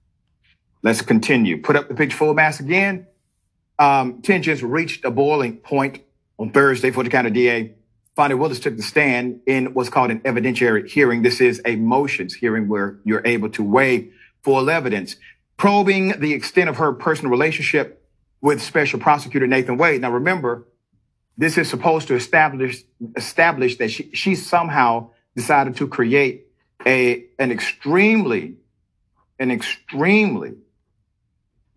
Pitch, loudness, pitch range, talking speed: 130 Hz, -18 LUFS, 120-155 Hz, 145 wpm